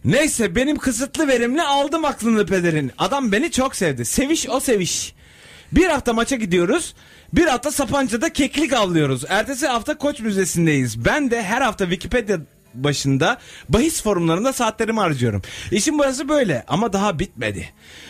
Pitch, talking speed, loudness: 225 Hz, 145 wpm, -19 LUFS